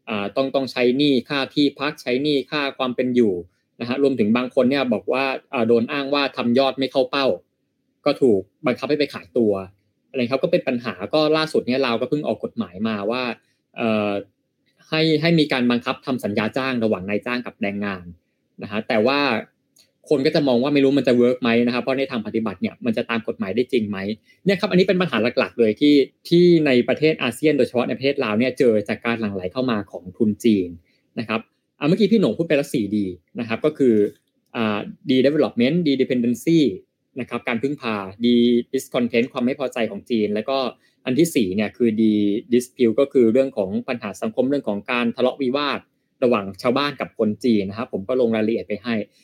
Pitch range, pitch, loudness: 110-140 Hz, 125 Hz, -21 LUFS